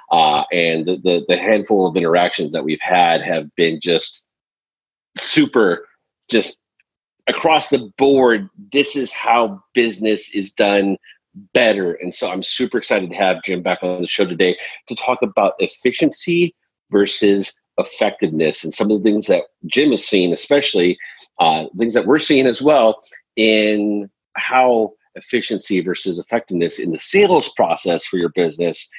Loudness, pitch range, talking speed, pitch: -17 LUFS, 95-135 Hz, 155 wpm, 110 Hz